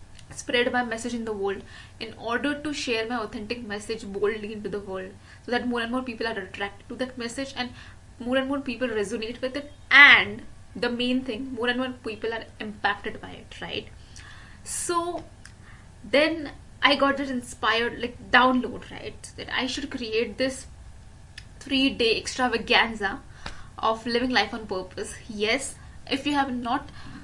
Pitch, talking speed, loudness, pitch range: 245 Hz, 165 wpm, -25 LUFS, 225-260 Hz